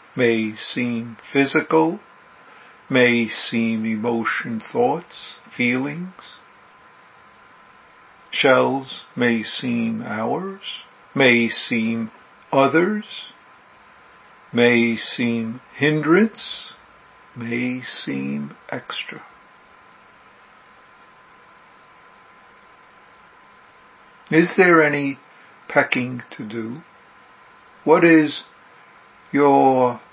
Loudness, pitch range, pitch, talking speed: -19 LUFS, 115-160 Hz, 130 Hz, 60 wpm